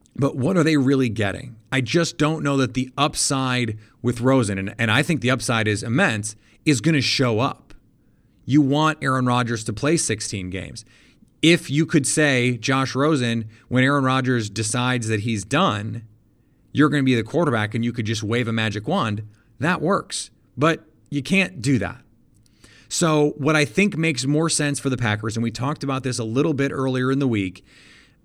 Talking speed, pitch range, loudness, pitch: 195 wpm, 115-145 Hz, -21 LUFS, 130 Hz